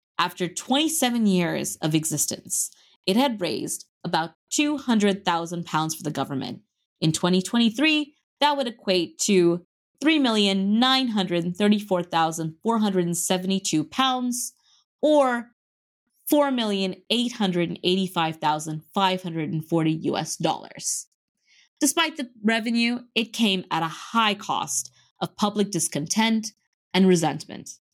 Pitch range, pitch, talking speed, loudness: 170-240 Hz, 195 Hz, 85 wpm, -24 LUFS